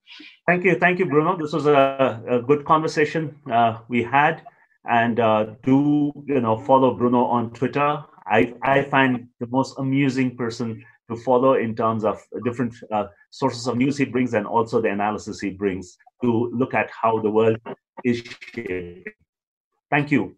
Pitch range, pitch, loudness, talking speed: 115-145 Hz, 125 Hz, -21 LUFS, 170 wpm